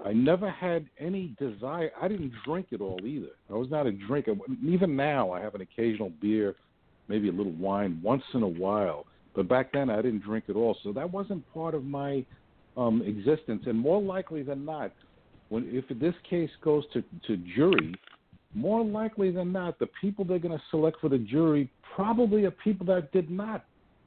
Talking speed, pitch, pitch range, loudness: 195 wpm, 150 Hz, 120-185 Hz, -30 LUFS